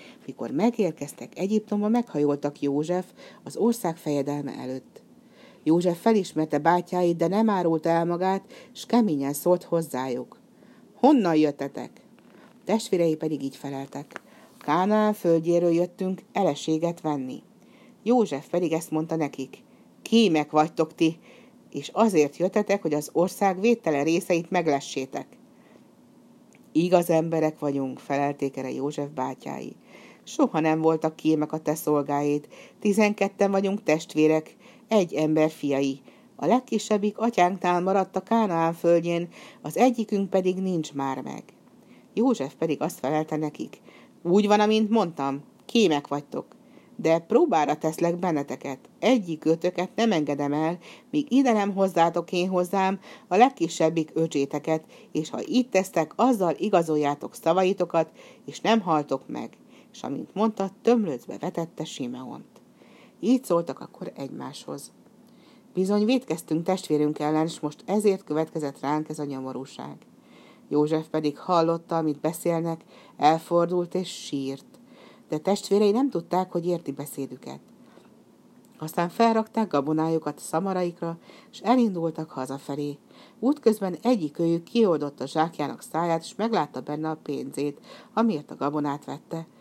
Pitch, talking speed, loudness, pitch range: 170 Hz, 125 wpm, -25 LUFS, 150-210 Hz